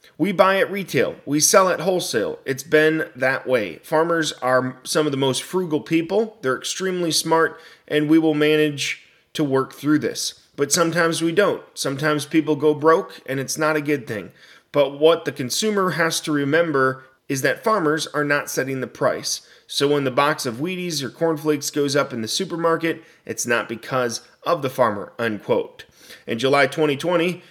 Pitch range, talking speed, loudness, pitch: 140-165 Hz, 185 wpm, -21 LUFS, 155 Hz